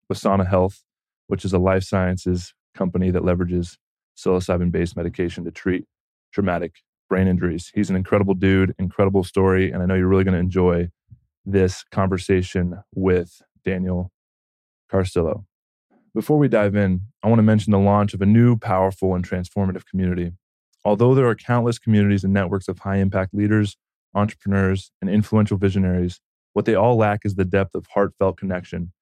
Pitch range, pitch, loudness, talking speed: 90-100 Hz, 95 Hz, -21 LUFS, 165 wpm